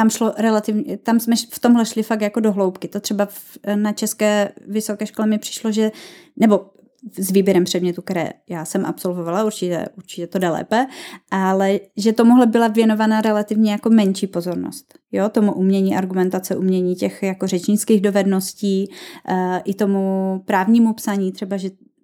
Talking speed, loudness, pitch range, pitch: 165 wpm, -19 LUFS, 190-220 Hz, 205 Hz